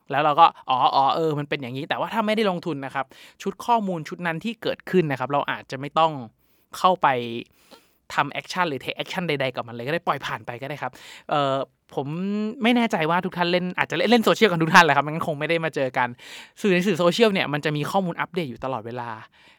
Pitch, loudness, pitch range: 160 Hz, -23 LUFS, 135-185 Hz